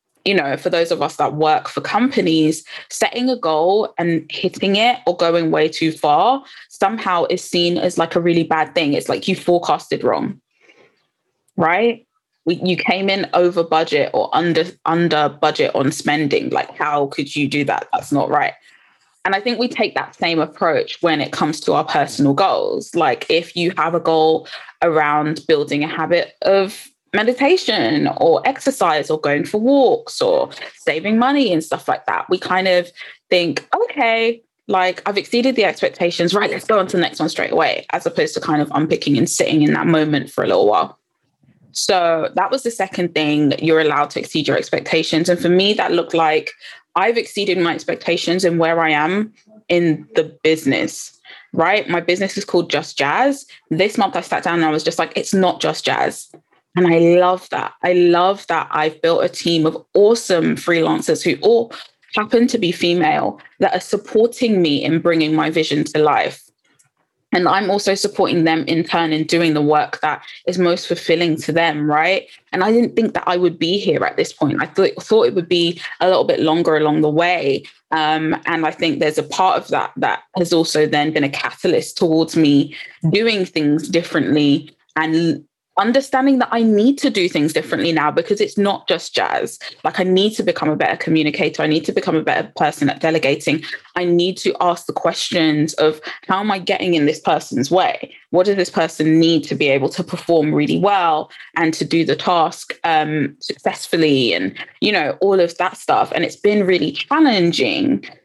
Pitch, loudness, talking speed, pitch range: 175 Hz, -17 LUFS, 195 wpm, 160-200 Hz